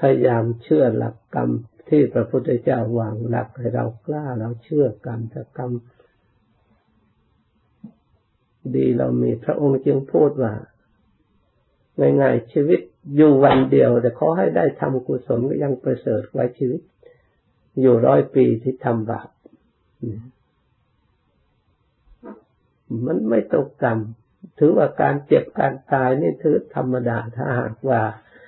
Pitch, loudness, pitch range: 120 Hz, -20 LUFS, 110-130 Hz